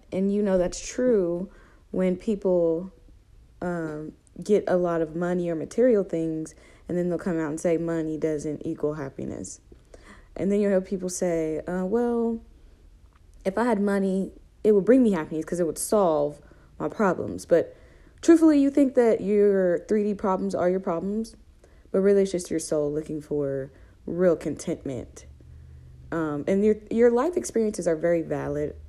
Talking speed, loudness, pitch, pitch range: 165 wpm, -25 LUFS, 175 Hz, 155-205 Hz